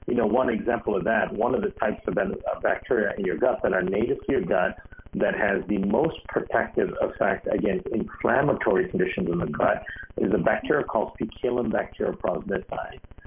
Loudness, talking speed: -25 LUFS, 175 wpm